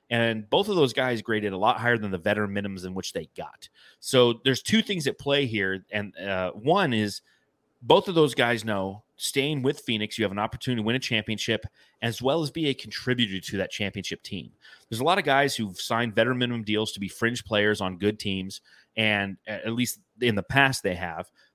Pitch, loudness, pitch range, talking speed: 115 Hz, -26 LUFS, 105-130 Hz, 220 wpm